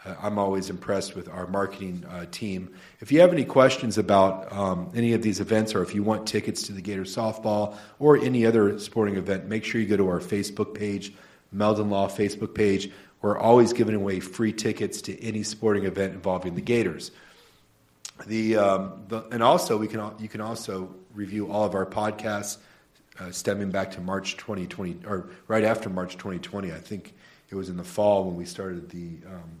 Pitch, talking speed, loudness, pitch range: 105 Hz, 195 wpm, -26 LUFS, 95-110 Hz